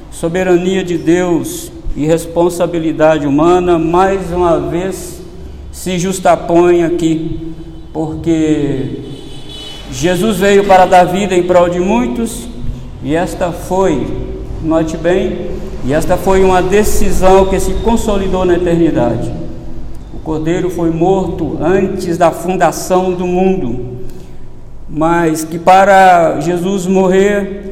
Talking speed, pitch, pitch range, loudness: 110 wpm, 175 Hz, 160-185 Hz, -12 LUFS